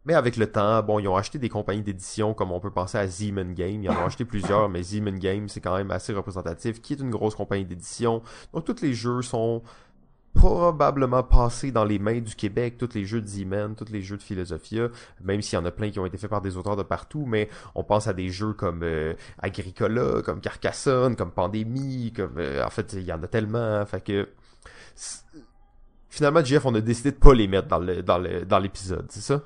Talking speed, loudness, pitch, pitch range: 235 wpm, -26 LUFS, 105 Hz, 95-115 Hz